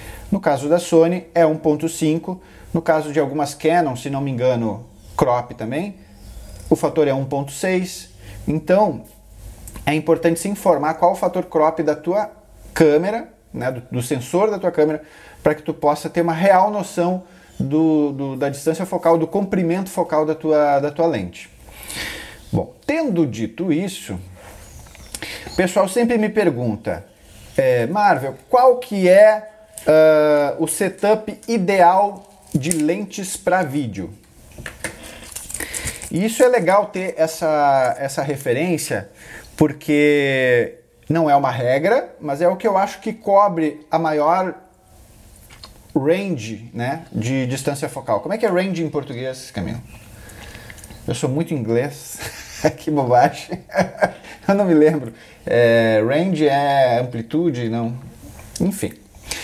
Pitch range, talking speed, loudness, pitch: 130-180 Hz, 135 wpm, -19 LUFS, 155 Hz